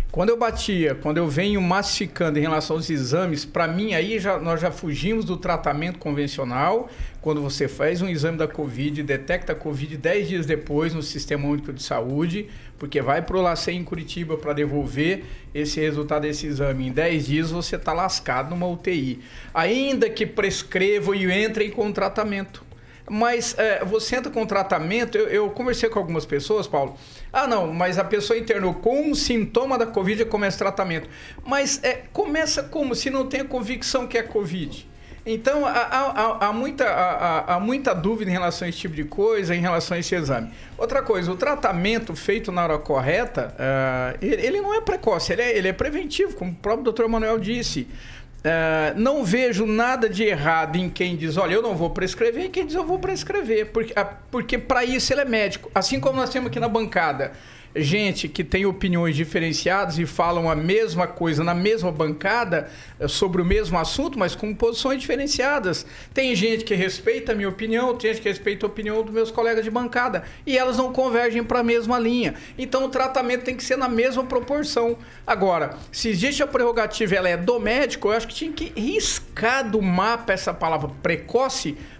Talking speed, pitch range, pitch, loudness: 195 wpm, 165-240 Hz, 205 Hz, -23 LUFS